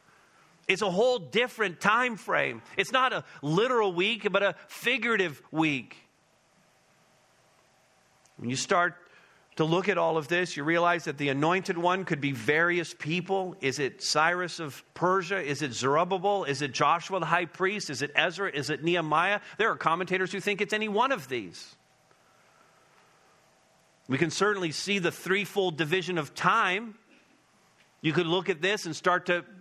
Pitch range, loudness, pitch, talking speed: 160-200 Hz, -27 LUFS, 180 Hz, 165 wpm